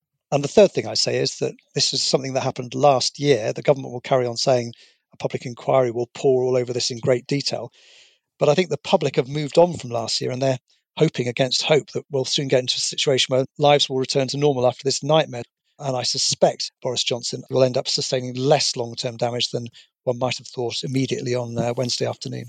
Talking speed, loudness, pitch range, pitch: 230 wpm, -21 LUFS, 125-145 Hz, 130 Hz